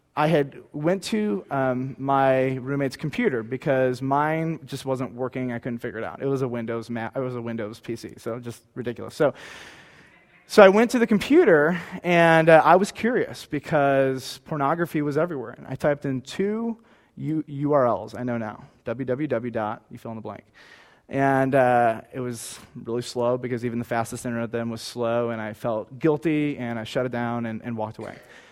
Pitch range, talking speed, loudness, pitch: 120-150 Hz, 190 wpm, -24 LUFS, 130 Hz